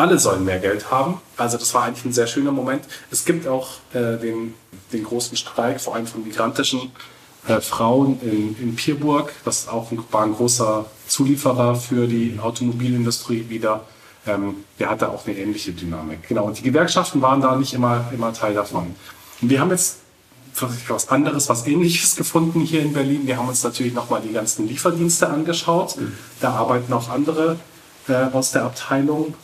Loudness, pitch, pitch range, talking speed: -20 LUFS, 125 Hz, 115-145 Hz, 180 wpm